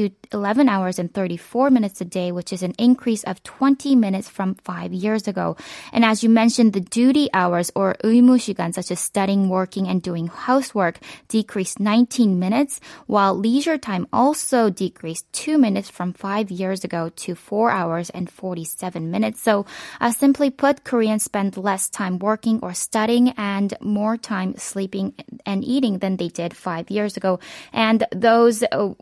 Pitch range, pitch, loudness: 185-230 Hz, 205 Hz, -20 LUFS